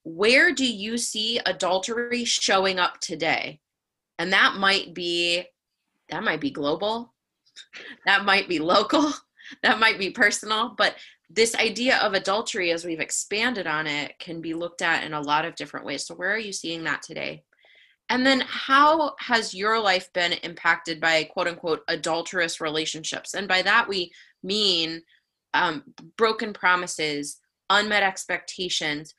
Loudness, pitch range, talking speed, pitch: -23 LUFS, 165-225 Hz, 150 wpm, 185 Hz